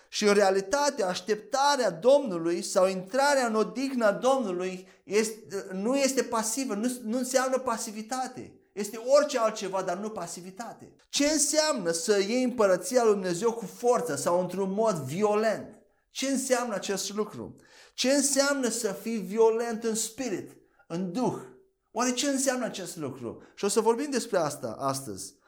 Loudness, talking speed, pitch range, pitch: -27 LUFS, 145 wpm, 195-260 Hz, 225 Hz